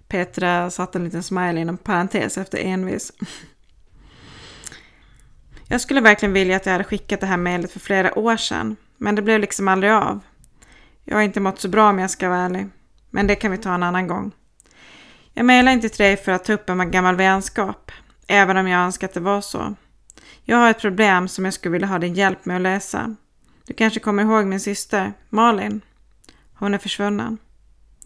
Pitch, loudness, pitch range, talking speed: 195 Hz, -19 LUFS, 185-210 Hz, 200 wpm